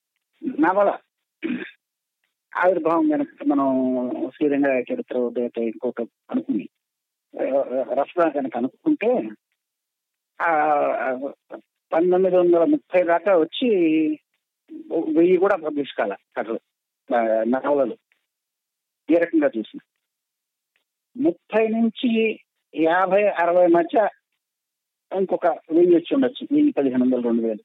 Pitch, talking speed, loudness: 180 Hz, 85 wpm, -21 LUFS